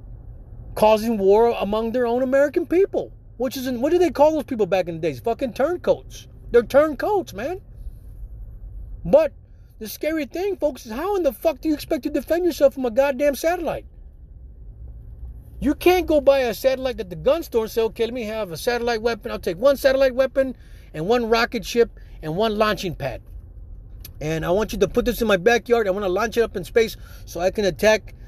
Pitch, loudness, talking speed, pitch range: 235 Hz, -21 LUFS, 210 wpm, 185-280 Hz